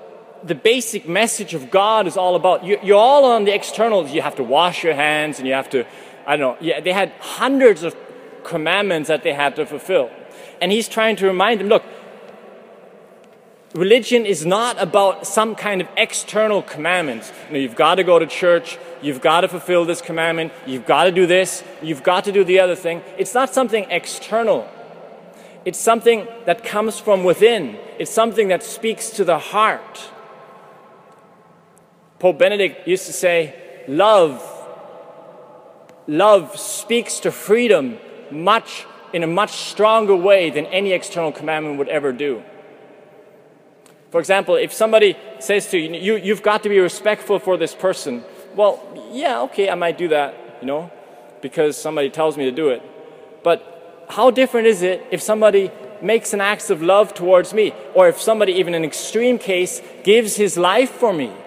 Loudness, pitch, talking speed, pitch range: -17 LUFS, 195 Hz, 175 wpm, 170-220 Hz